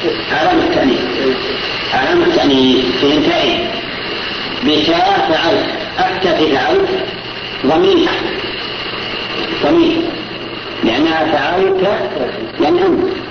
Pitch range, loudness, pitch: 335-375 Hz, -14 LUFS, 350 Hz